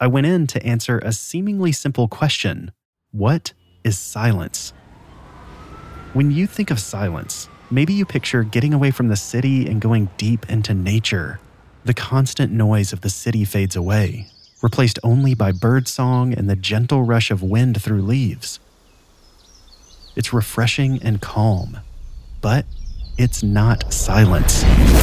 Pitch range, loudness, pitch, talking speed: 100-125 Hz, -19 LUFS, 110 Hz, 140 wpm